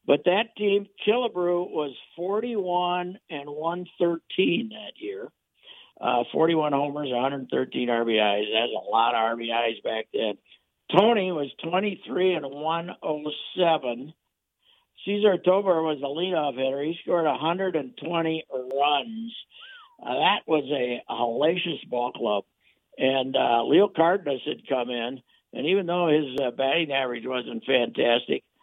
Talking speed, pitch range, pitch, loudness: 130 wpm, 135-185 Hz, 160 Hz, -25 LUFS